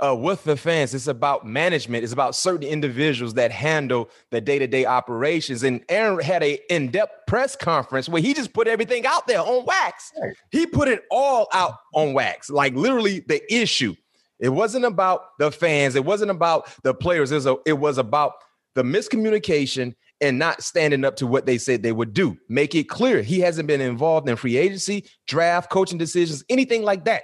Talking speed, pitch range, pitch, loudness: 195 wpm, 135-195 Hz, 155 Hz, -21 LUFS